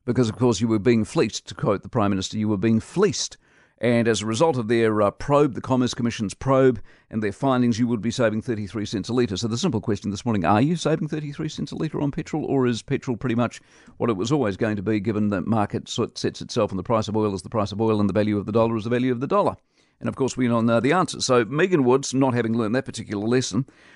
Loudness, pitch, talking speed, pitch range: -23 LUFS, 115 Hz, 285 wpm, 110-130 Hz